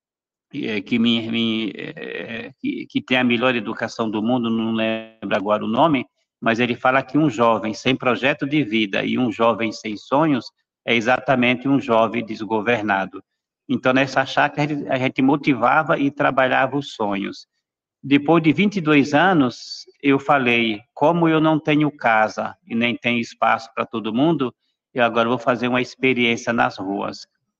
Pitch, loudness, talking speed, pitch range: 120 Hz, -20 LUFS, 150 wpm, 115-140 Hz